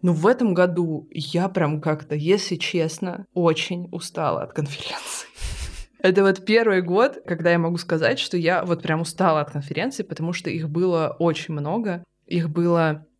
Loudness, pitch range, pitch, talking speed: -22 LUFS, 160-185 Hz, 170 Hz, 165 wpm